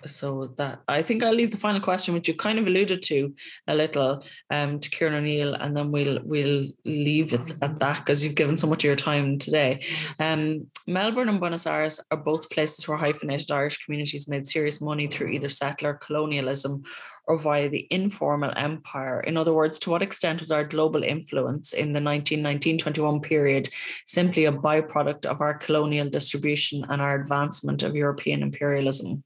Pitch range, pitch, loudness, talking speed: 140-155 Hz, 150 Hz, -25 LUFS, 185 wpm